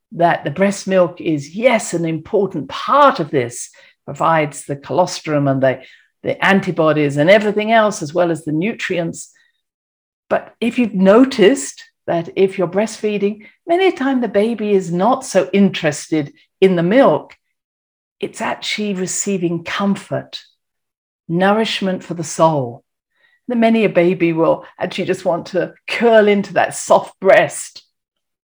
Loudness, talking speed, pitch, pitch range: -16 LUFS, 145 wpm, 190 Hz, 170-220 Hz